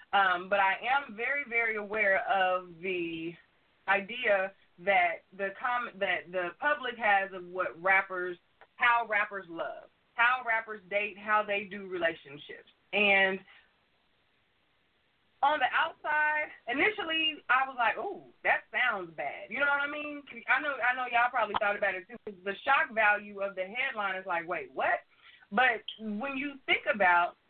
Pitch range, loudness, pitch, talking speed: 195-265 Hz, -29 LUFS, 215 Hz, 160 wpm